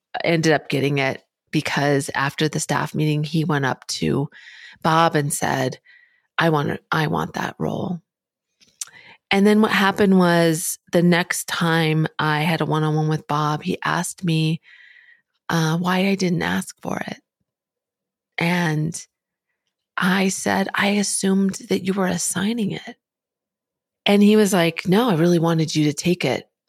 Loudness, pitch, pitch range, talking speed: -20 LUFS, 170 Hz, 155-195 Hz, 155 wpm